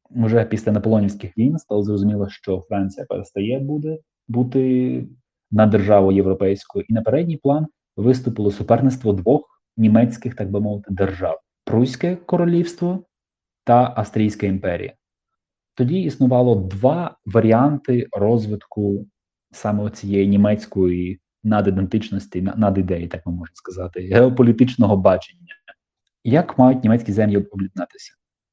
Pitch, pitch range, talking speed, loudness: 105 Hz, 100-125 Hz, 115 wpm, -19 LUFS